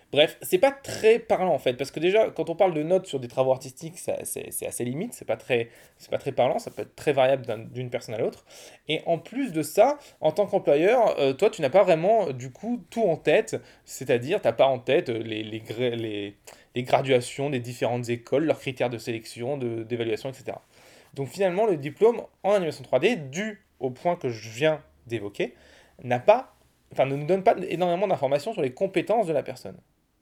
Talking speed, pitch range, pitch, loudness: 215 wpm, 125-190 Hz, 145 Hz, -25 LUFS